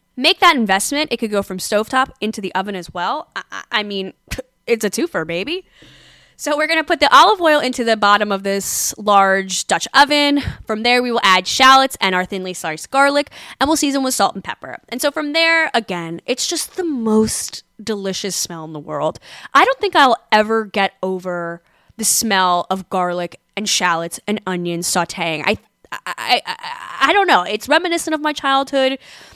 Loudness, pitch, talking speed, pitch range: -16 LUFS, 220 Hz, 190 wpm, 185-285 Hz